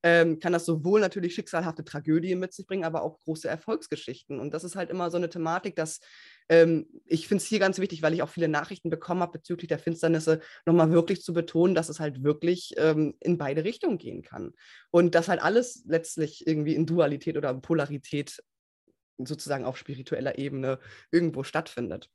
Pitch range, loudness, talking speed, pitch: 150-175 Hz, -27 LUFS, 190 wpm, 165 Hz